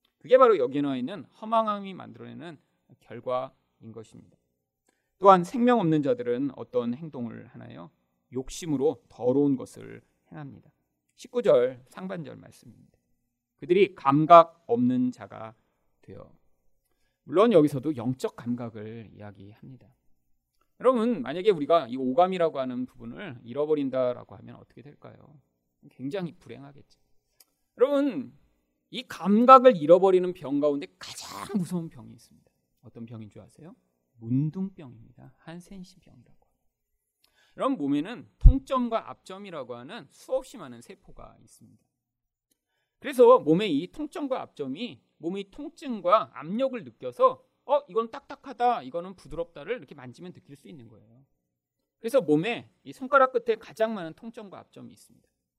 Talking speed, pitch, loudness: 310 characters per minute, 165 Hz, -25 LUFS